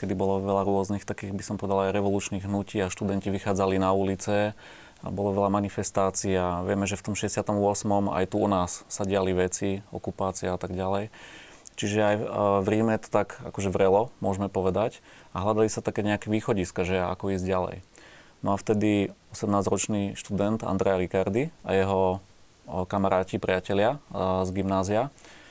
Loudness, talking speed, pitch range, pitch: -27 LUFS, 165 wpm, 95-105 Hz, 100 Hz